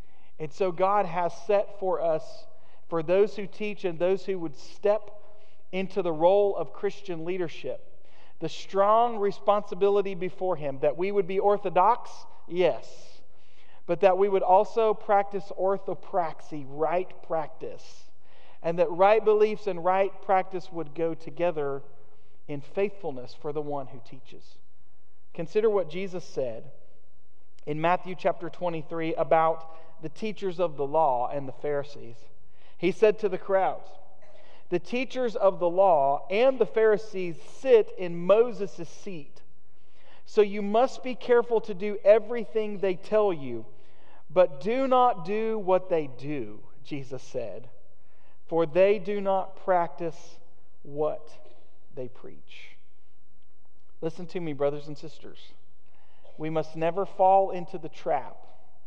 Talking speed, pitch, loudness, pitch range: 135 wpm, 180 Hz, -27 LUFS, 155-200 Hz